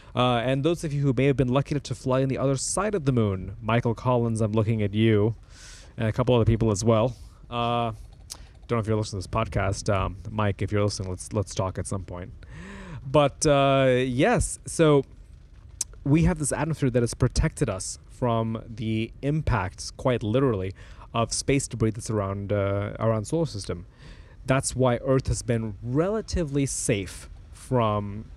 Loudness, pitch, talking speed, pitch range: -25 LUFS, 115 Hz, 185 wpm, 100-130 Hz